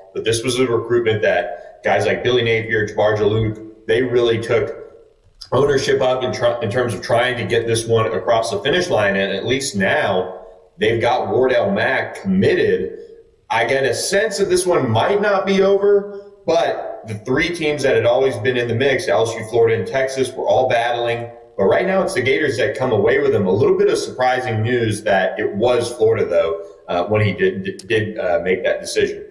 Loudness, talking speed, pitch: -18 LUFS, 205 wpm, 130 Hz